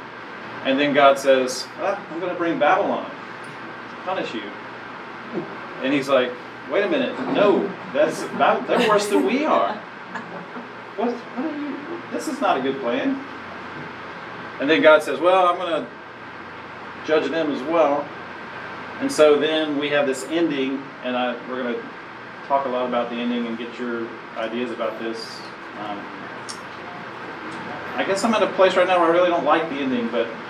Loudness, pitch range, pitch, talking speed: -21 LUFS, 125-190 Hz, 155 Hz, 175 wpm